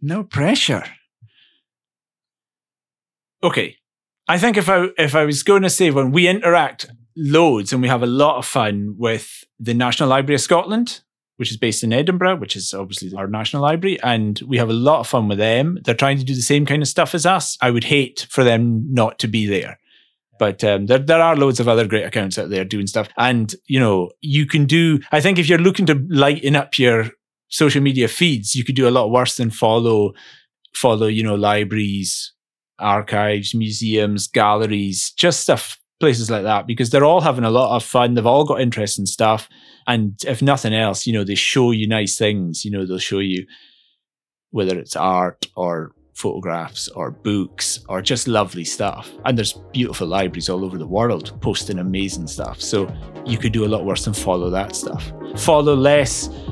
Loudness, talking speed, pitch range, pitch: -18 LUFS, 195 wpm, 105-140 Hz, 120 Hz